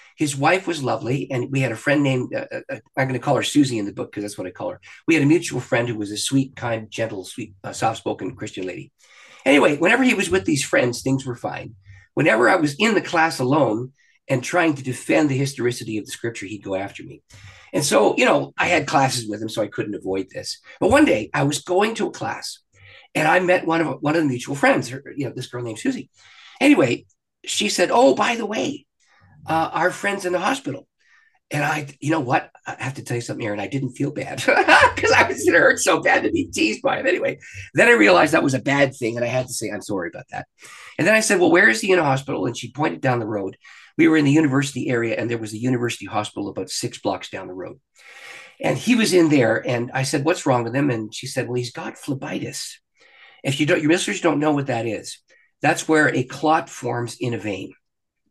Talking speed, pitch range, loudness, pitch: 255 wpm, 120-165 Hz, -20 LUFS, 135 Hz